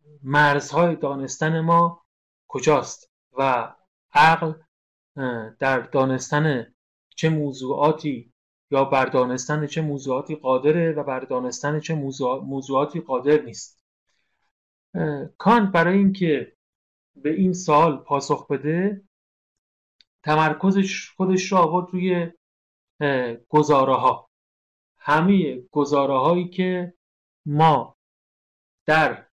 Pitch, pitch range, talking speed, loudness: 150 Hz, 130-165 Hz, 90 wpm, -21 LUFS